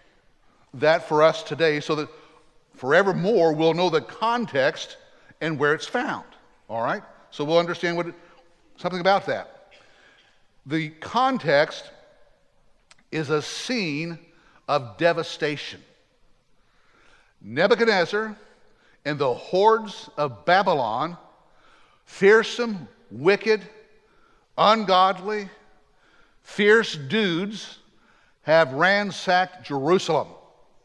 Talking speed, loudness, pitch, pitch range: 90 wpm, -22 LUFS, 175 Hz, 155-215 Hz